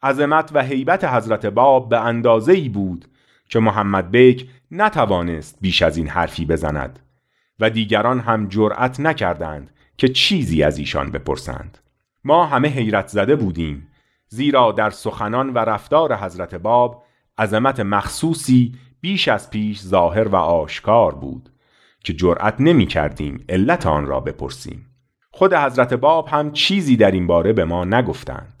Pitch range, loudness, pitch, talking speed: 100-135 Hz, -17 LUFS, 115 Hz, 145 wpm